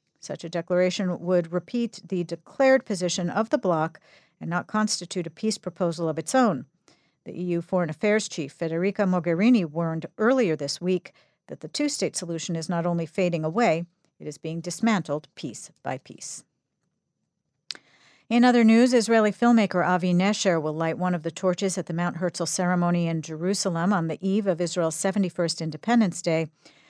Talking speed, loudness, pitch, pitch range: 170 wpm, -25 LUFS, 180 Hz, 170-205 Hz